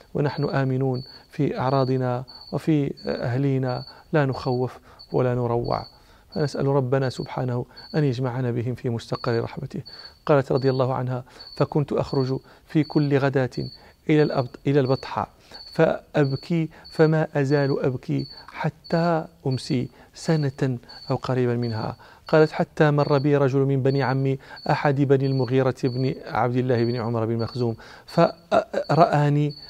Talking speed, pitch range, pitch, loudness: 120 wpm, 125-145 Hz, 135 Hz, -24 LUFS